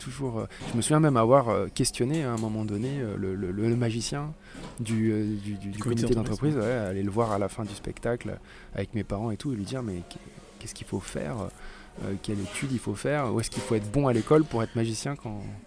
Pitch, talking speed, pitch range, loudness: 115 Hz, 220 wpm, 105-125 Hz, -28 LUFS